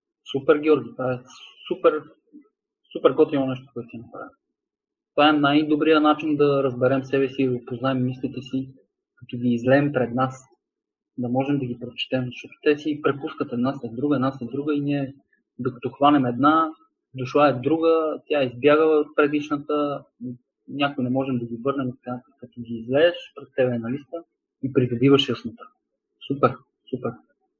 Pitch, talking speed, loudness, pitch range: 135 Hz, 165 wpm, -23 LUFS, 125-150 Hz